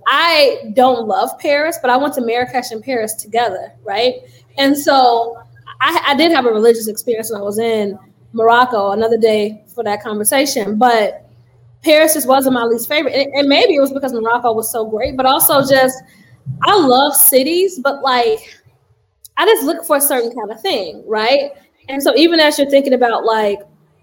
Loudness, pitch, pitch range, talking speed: -14 LUFS, 245 Hz, 220-275 Hz, 185 wpm